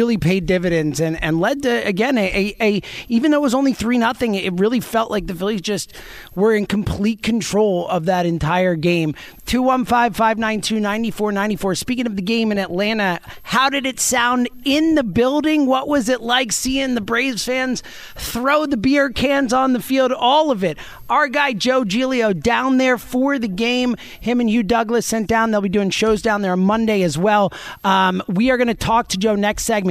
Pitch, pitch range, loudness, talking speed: 225 Hz, 200-255 Hz, -18 LUFS, 200 wpm